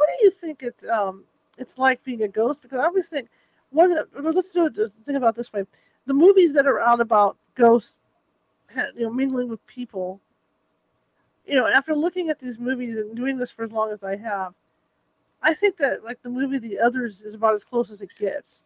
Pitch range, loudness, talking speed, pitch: 220-285 Hz, -22 LUFS, 220 wpm, 245 Hz